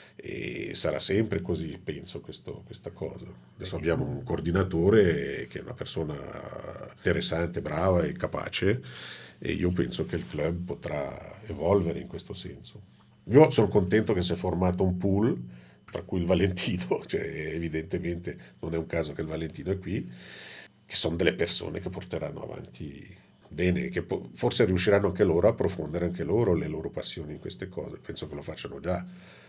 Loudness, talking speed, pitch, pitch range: -28 LUFS, 170 wpm, 85 Hz, 80-95 Hz